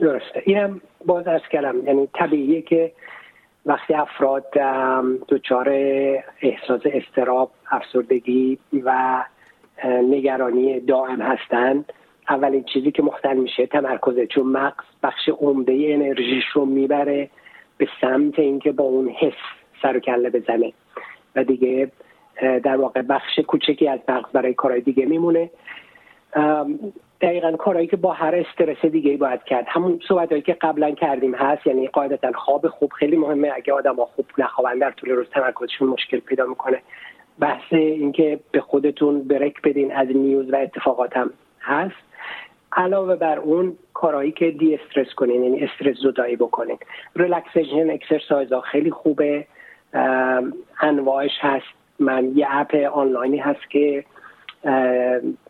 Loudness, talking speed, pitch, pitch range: -20 LUFS, 135 wpm, 140 Hz, 130-155 Hz